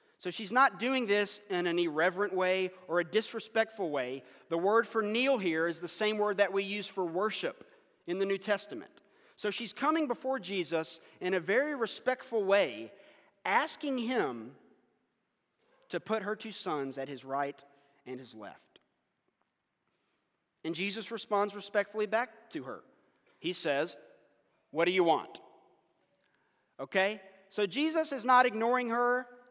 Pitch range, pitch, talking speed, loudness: 175-230 Hz, 205 Hz, 150 wpm, -32 LUFS